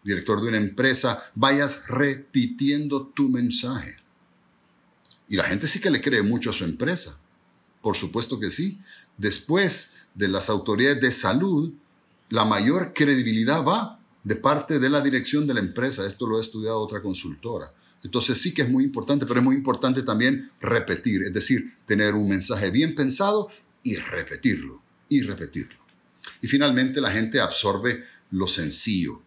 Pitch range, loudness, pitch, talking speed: 110-145 Hz, -22 LUFS, 130 Hz, 160 wpm